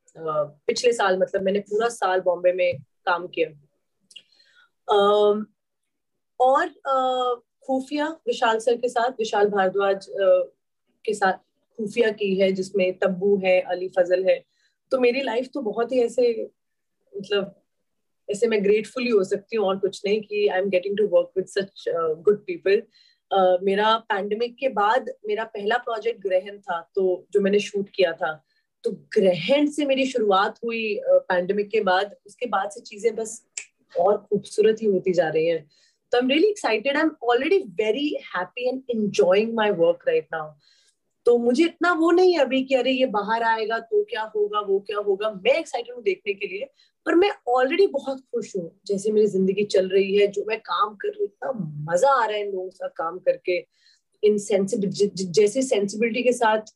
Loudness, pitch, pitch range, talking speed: -23 LUFS, 220 Hz, 195-270 Hz, 180 wpm